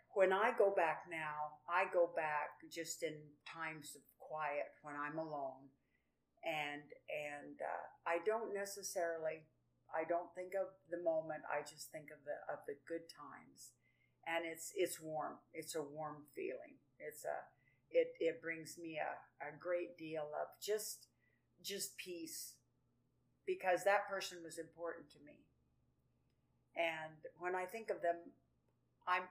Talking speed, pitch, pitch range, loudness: 150 wpm, 165 Hz, 150-185 Hz, -43 LUFS